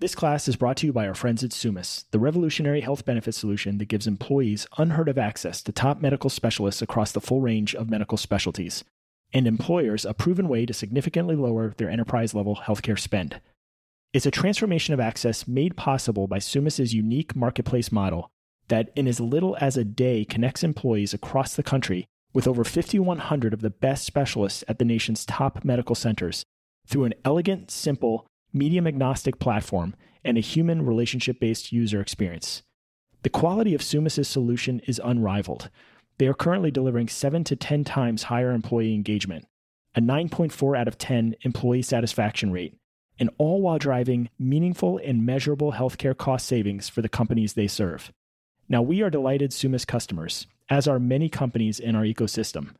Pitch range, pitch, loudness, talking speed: 110-140 Hz, 120 Hz, -25 LUFS, 170 wpm